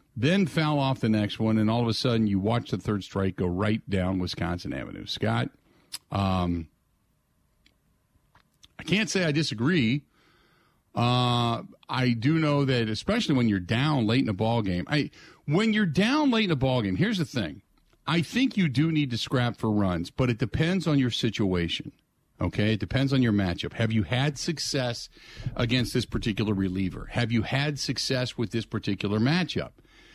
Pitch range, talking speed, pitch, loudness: 110-150 Hz, 180 wpm, 120 Hz, -26 LUFS